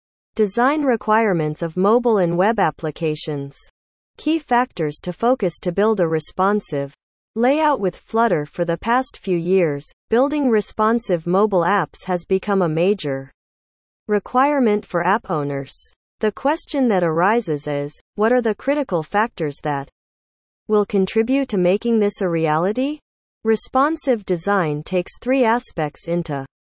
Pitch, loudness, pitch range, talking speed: 195 Hz, -20 LUFS, 165-230 Hz, 135 wpm